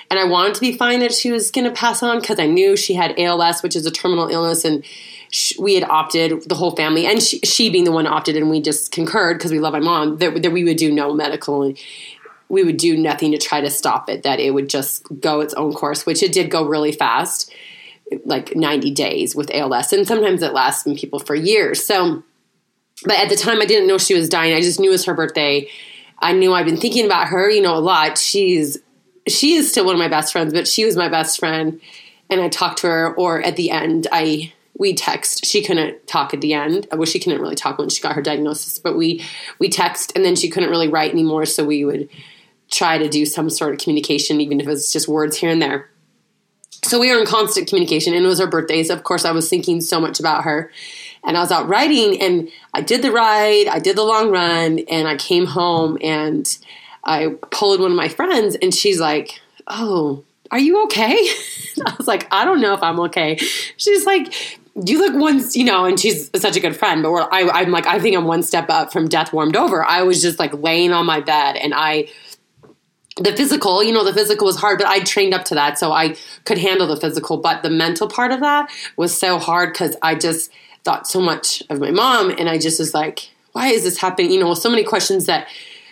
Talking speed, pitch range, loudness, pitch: 240 wpm, 160-245 Hz, -16 LUFS, 175 Hz